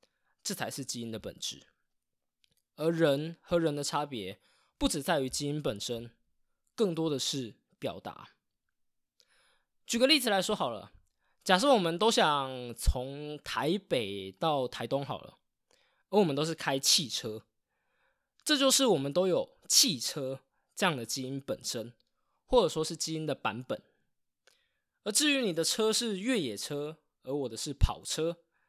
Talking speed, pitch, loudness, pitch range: 210 characters per minute, 155 Hz, -30 LUFS, 135-215 Hz